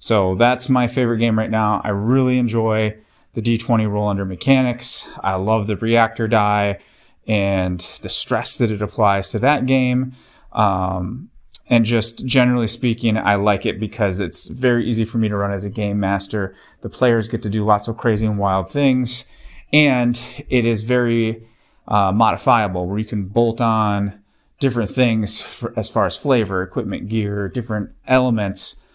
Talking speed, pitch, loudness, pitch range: 170 wpm, 110 Hz, -19 LUFS, 105-120 Hz